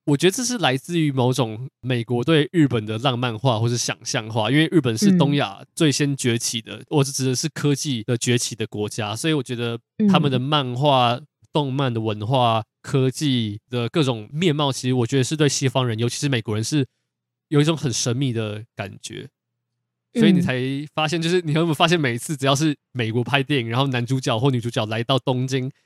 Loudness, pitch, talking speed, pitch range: -21 LUFS, 130 Hz, 315 characters per minute, 120-150 Hz